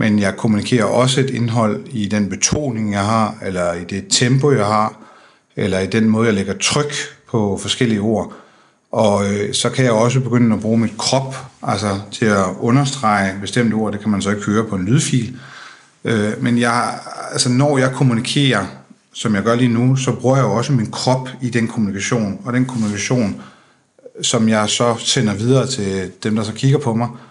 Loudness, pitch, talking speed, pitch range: -17 LUFS, 115 Hz, 195 wpm, 105-125 Hz